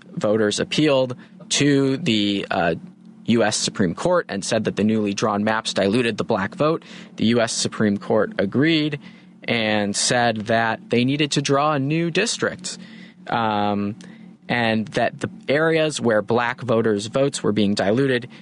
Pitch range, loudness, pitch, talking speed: 110-160 Hz, -21 LUFS, 130 Hz, 150 wpm